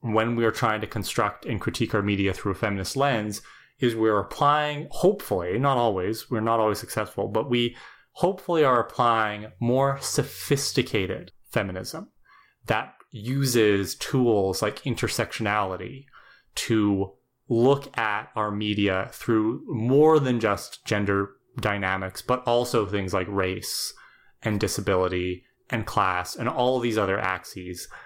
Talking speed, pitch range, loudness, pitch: 130 wpm, 100-125 Hz, -25 LUFS, 110 Hz